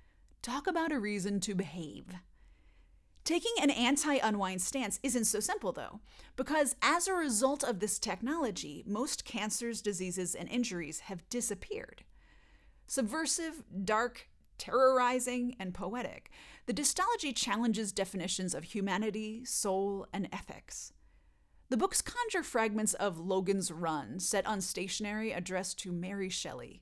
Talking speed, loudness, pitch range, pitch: 125 wpm, -34 LUFS, 190-255 Hz, 215 Hz